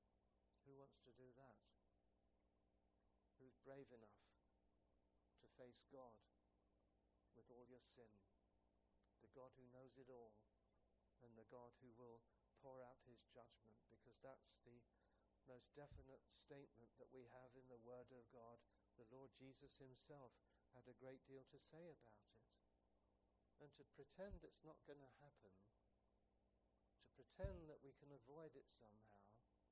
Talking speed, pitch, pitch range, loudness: 145 wpm, 120 Hz, 100-130 Hz, -65 LUFS